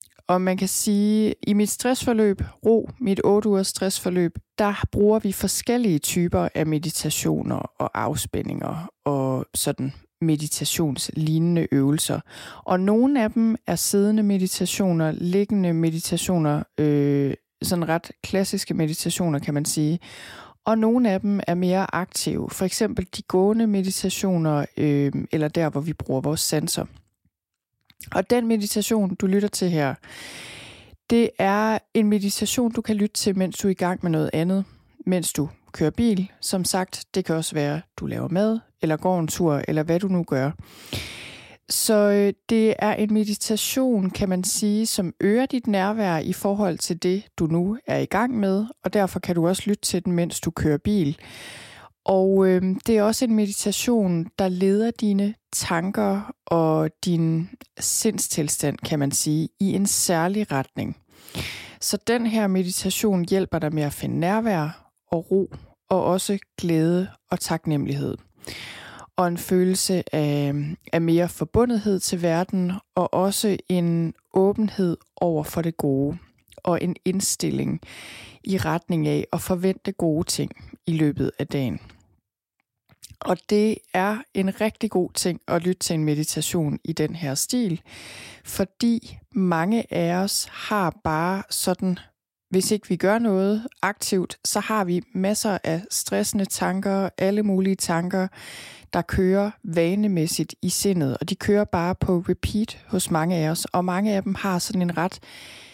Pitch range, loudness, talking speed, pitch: 165-205 Hz, -23 LUFS, 155 wpm, 185 Hz